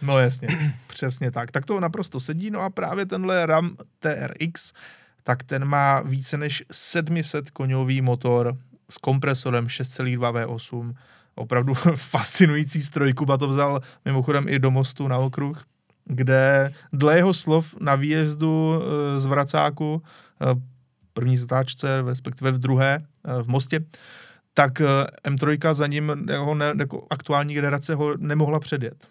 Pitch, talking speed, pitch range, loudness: 140 Hz, 135 wpm, 130-155 Hz, -23 LUFS